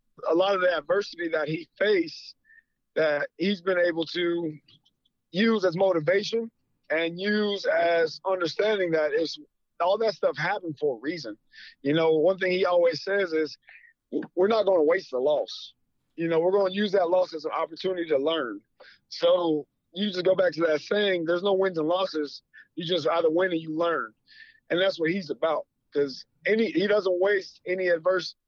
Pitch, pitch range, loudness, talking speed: 180 Hz, 165-205 Hz, -26 LUFS, 190 wpm